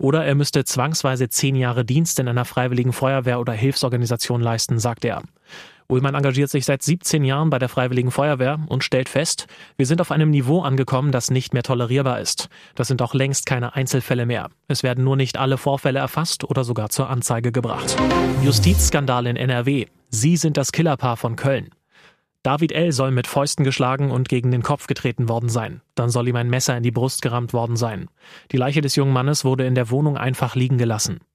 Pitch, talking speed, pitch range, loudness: 130 Hz, 200 wpm, 125-140 Hz, -20 LUFS